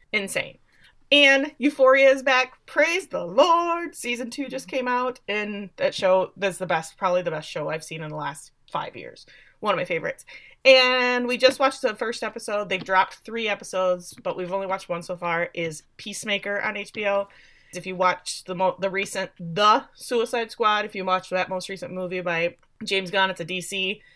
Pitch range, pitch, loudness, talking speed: 185-250 Hz, 200 Hz, -23 LUFS, 195 wpm